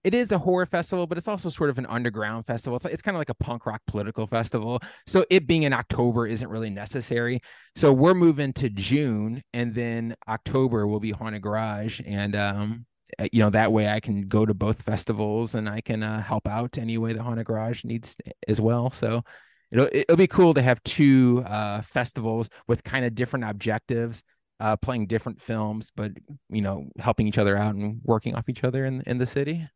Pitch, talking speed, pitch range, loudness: 115 Hz, 210 wpm, 110-130 Hz, -25 LUFS